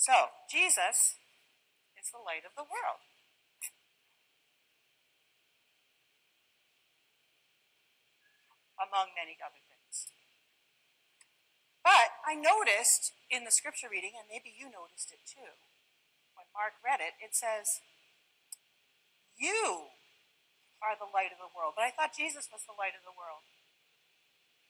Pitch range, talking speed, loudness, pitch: 195-310 Hz, 115 wpm, -31 LUFS, 230 Hz